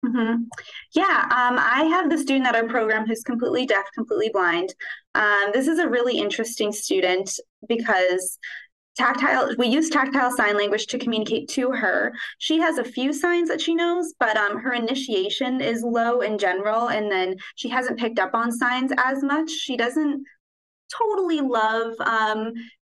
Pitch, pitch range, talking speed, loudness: 245 Hz, 220-285 Hz, 170 wpm, -22 LUFS